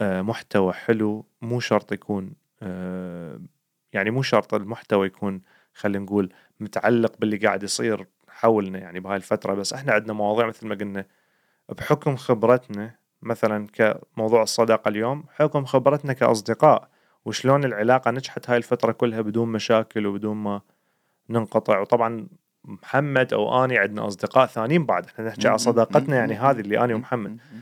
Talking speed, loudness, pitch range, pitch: 145 wpm, -23 LUFS, 105-125 Hz, 110 Hz